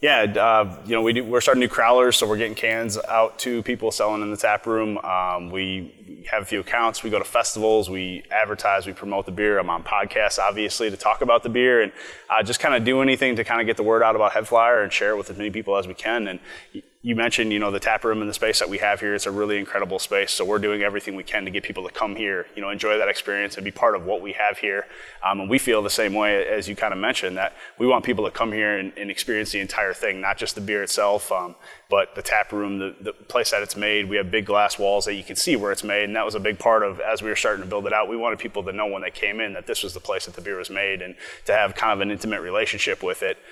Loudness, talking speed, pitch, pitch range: -22 LUFS, 295 wpm, 105 Hz, 100-115 Hz